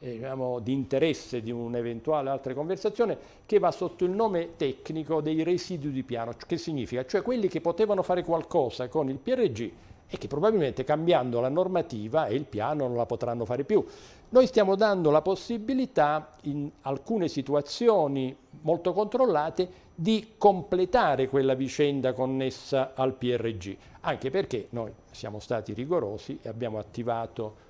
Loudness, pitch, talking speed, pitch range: -28 LUFS, 150 Hz, 145 wpm, 125-180 Hz